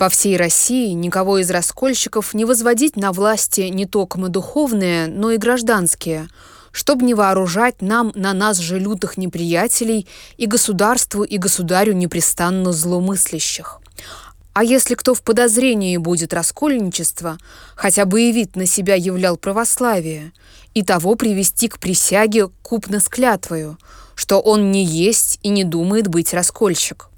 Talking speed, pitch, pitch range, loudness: 135 wpm, 195 Hz, 180-225 Hz, -16 LUFS